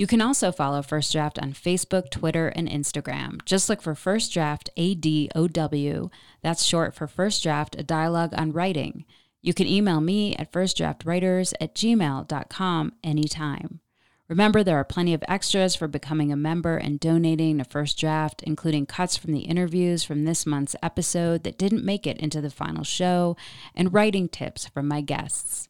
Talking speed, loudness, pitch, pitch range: 175 wpm, -25 LUFS, 165 Hz, 150-180 Hz